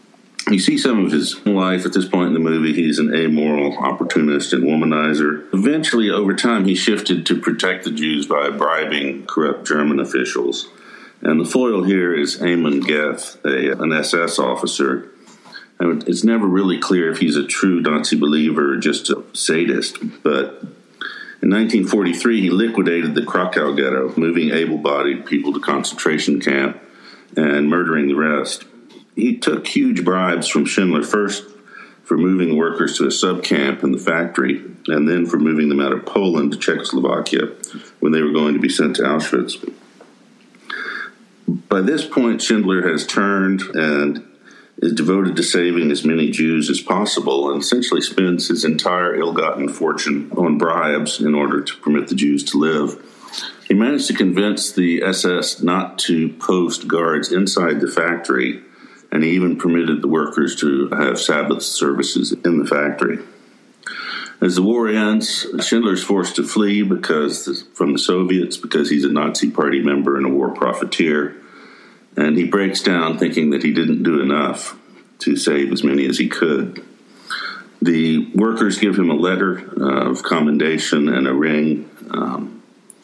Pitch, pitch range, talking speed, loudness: 80 Hz, 75-95 Hz, 160 wpm, -17 LUFS